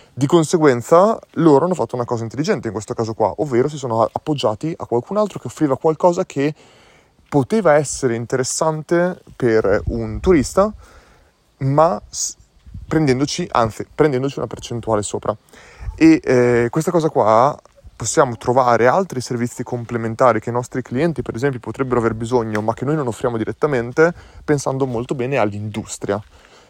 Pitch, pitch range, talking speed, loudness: 125 Hz, 115-155 Hz, 145 wpm, -18 LUFS